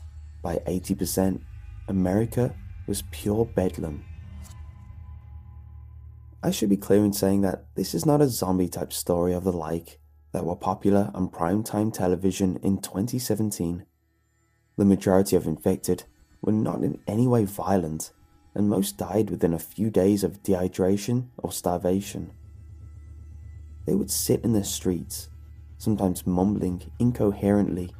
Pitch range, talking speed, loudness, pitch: 85-100 Hz, 130 wpm, -25 LUFS, 95 Hz